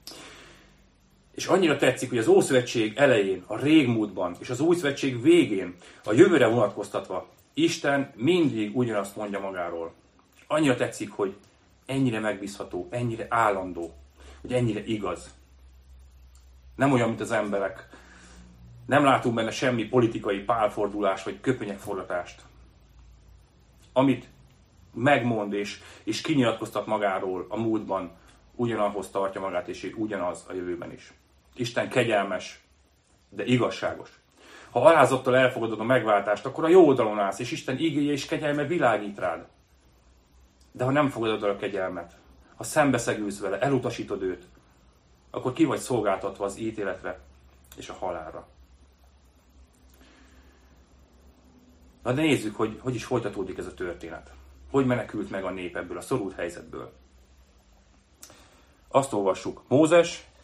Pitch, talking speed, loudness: 95 Hz, 125 wpm, -26 LUFS